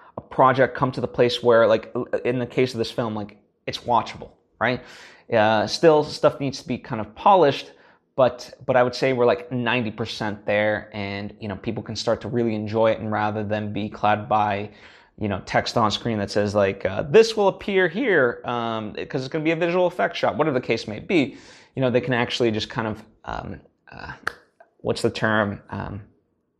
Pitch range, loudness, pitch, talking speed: 105-125 Hz, -22 LUFS, 115 Hz, 215 wpm